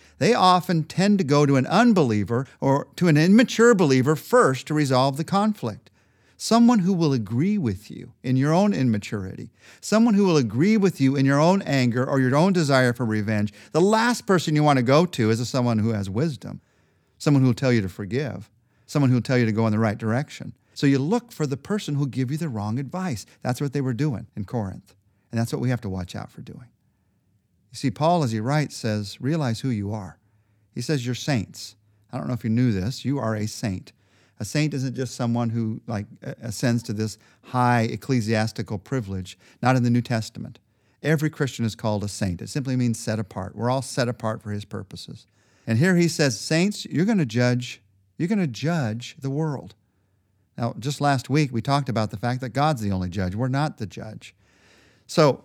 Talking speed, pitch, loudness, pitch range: 215 wpm, 125 Hz, -23 LUFS, 110-150 Hz